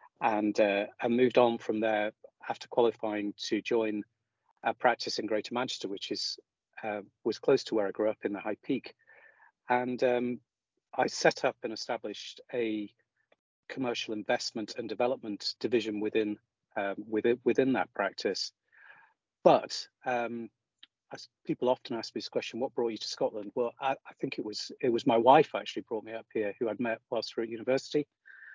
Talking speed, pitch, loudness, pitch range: 180 wpm, 120 Hz, -31 LUFS, 110-135 Hz